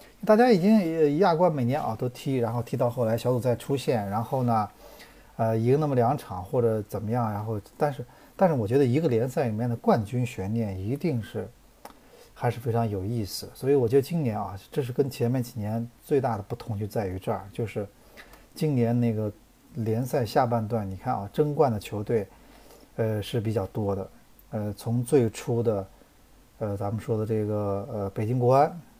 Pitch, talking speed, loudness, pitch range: 115 Hz, 280 characters per minute, -27 LUFS, 110-130 Hz